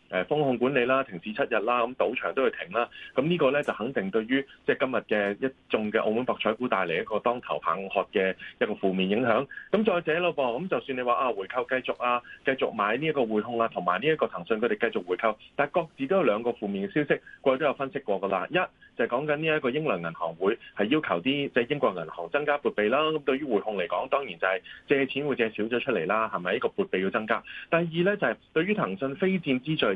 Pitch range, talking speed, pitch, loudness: 110-145 Hz, 375 characters per minute, 130 Hz, -27 LUFS